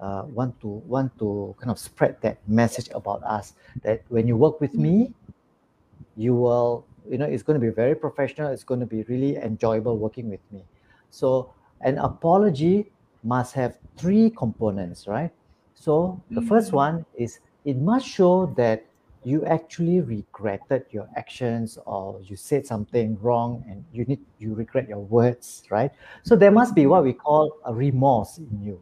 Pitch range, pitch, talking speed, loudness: 110-150 Hz, 120 Hz, 175 wpm, -23 LUFS